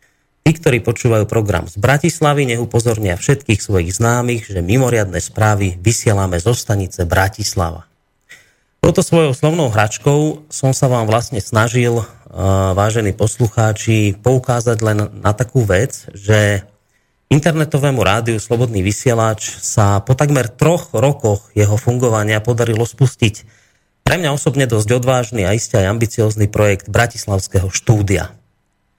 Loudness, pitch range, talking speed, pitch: -15 LUFS, 100-125 Hz, 125 wpm, 115 Hz